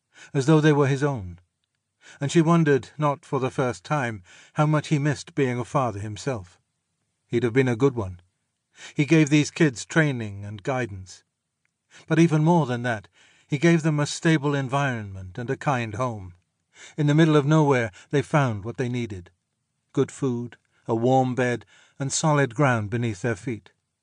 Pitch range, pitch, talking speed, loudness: 115-150 Hz, 130 Hz, 175 wpm, -23 LUFS